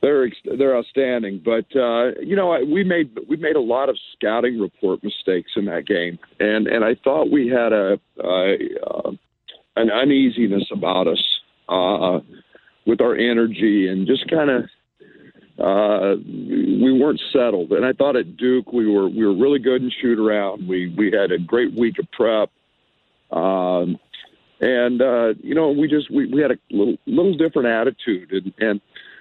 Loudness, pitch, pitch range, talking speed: -19 LUFS, 120 Hz, 105-155 Hz, 175 wpm